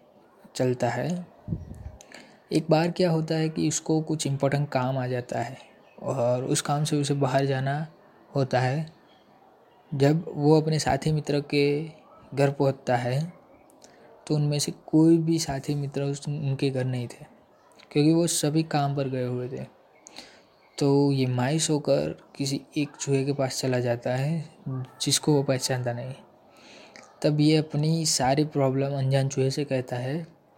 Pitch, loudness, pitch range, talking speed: 145 Hz, -26 LUFS, 135-155 Hz, 155 wpm